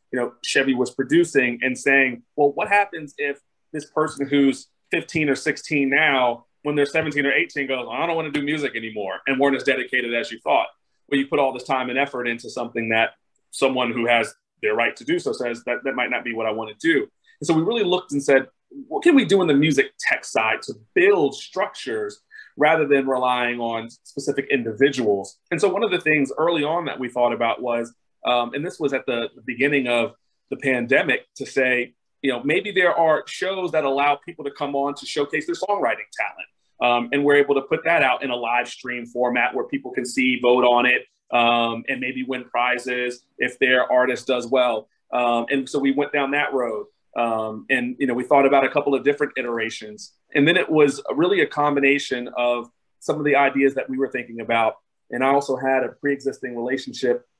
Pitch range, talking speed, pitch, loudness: 120-150 Hz, 215 wpm, 135 Hz, -21 LUFS